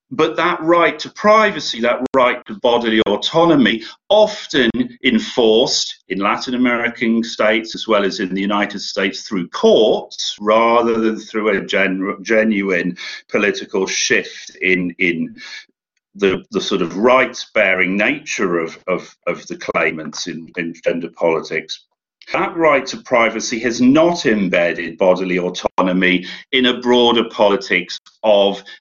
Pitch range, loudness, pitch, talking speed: 100-165 Hz, -16 LUFS, 115 Hz, 135 wpm